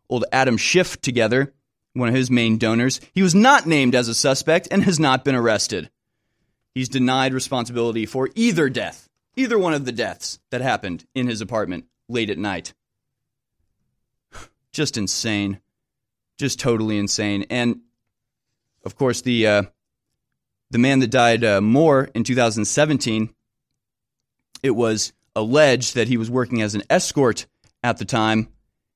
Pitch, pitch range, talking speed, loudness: 120 Hz, 110-130 Hz, 145 wpm, -20 LUFS